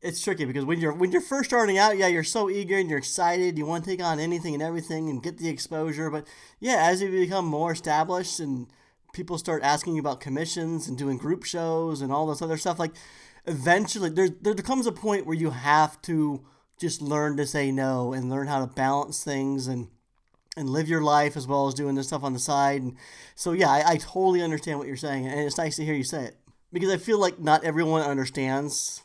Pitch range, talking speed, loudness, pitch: 140-175 Hz, 230 wpm, -26 LUFS, 155 Hz